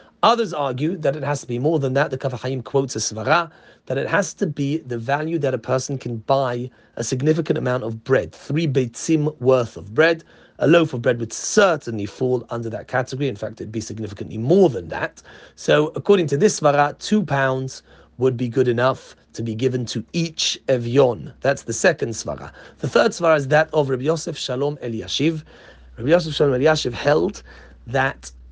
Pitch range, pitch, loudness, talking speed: 120-155 Hz, 135 Hz, -21 LUFS, 195 wpm